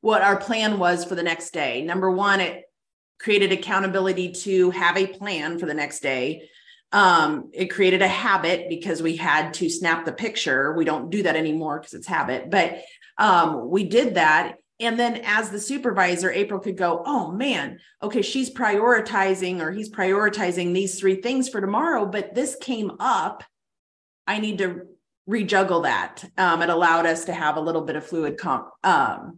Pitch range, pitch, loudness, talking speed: 170-205 Hz, 190 Hz, -22 LUFS, 180 wpm